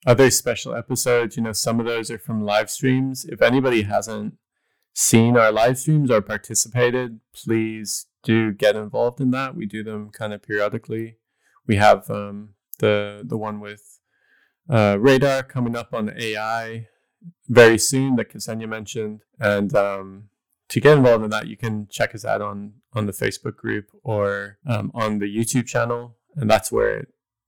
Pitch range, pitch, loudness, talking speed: 105-120 Hz, 115 Hz, -20 LUFS, 175 wpm